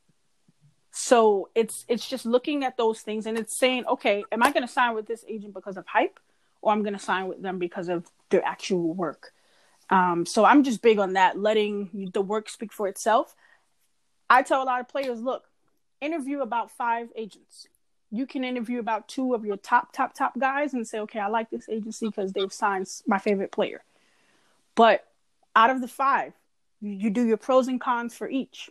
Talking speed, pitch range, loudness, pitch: 200 wpm, 200-250 Hz, -25 LUFS, 225 Hz